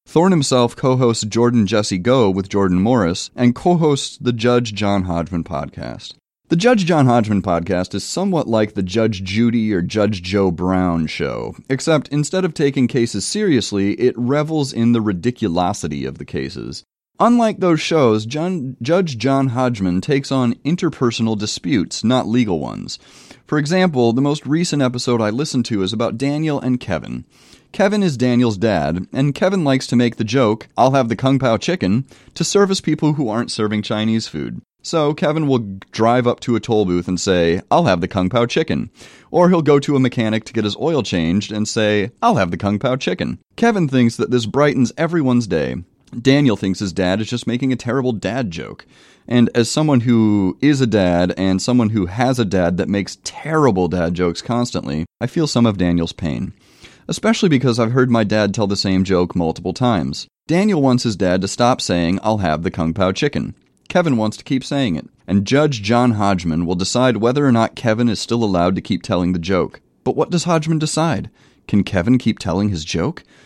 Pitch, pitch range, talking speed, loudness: 115 Hz, 95-135 Hz, 195 wpm, -17 LUFS